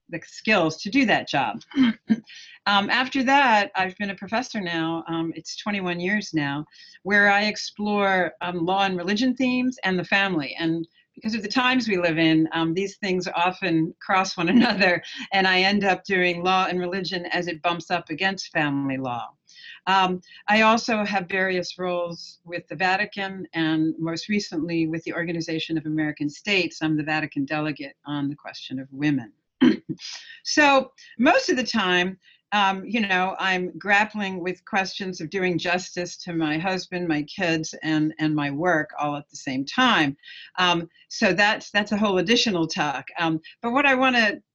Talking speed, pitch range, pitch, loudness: 175 wpm, 165-210 Hz, 185 Hz, -23 LUFS